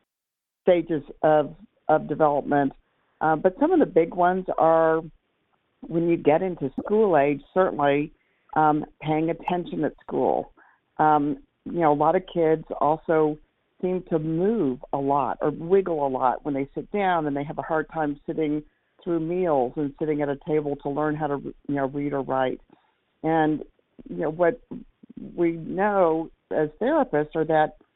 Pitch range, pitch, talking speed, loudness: 145-170 Hz, 155 Hz, 165 wpm, -24 LUFS